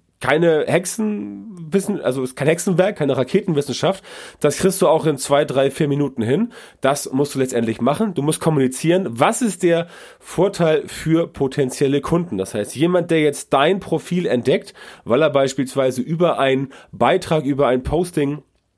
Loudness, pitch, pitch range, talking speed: -19 LUFS, 150 Hz, 135-175 Hz, 165 wpm